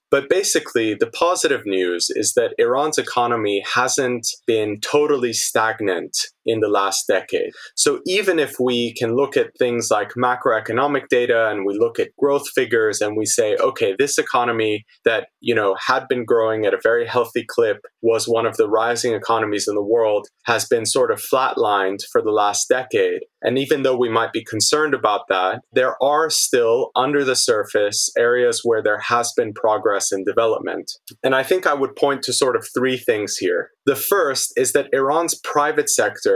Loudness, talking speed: -19 LUFS, 185 wpm